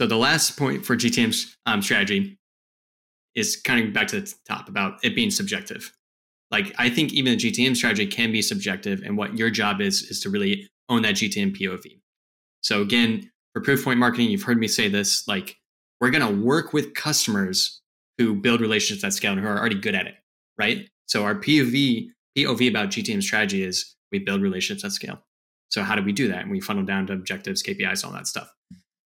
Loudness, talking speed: -23 LUFS, 210 wpm